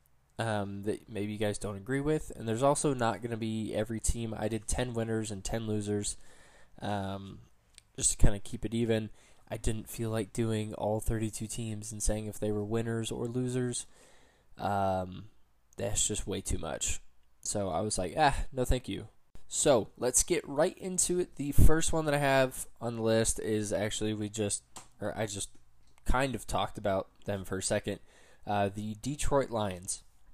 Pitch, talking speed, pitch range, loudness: 110 Hz, 190 wpm, 100-115 Hz, -32 LUFS